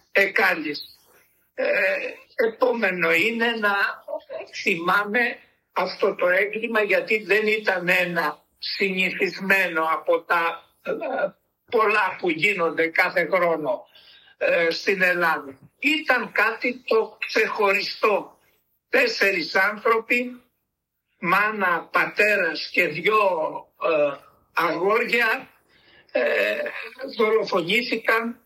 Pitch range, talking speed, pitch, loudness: 185-245 Hz, 80 wpm, 215 Hz, -22 LUFS